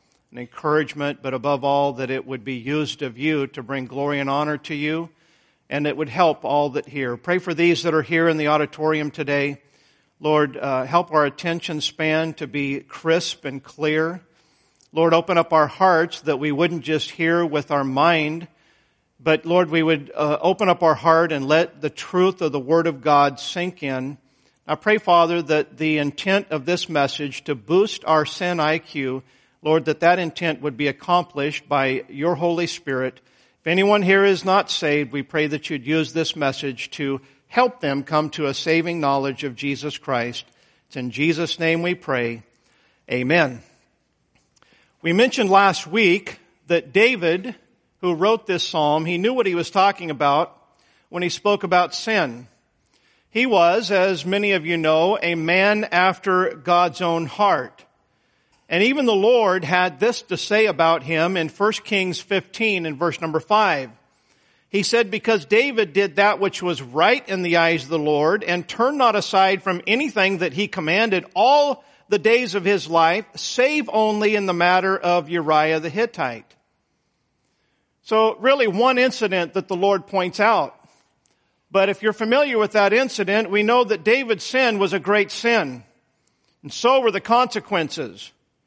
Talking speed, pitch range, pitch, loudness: 175 wpm, 150-195 Hz, 170 Hz, -20 LUFS